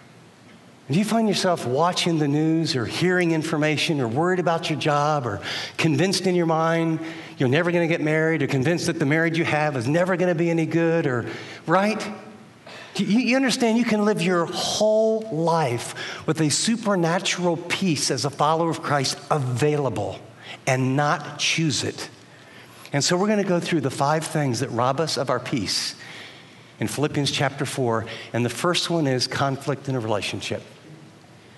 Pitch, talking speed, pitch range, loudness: 160 Hz, 180 wpm, 135-175 Hz, -22 LUFS